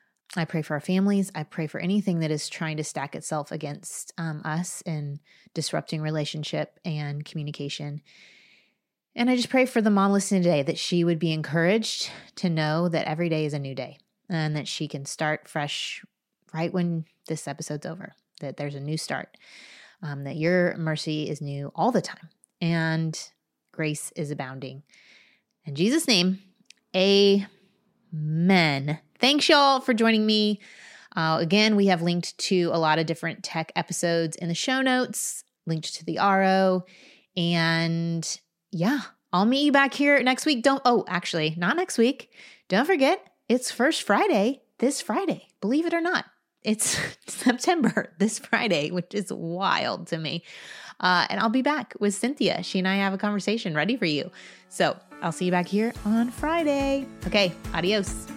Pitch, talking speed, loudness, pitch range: 180 Hz, 170 wpm, -25 LUFS, 160-220 Hz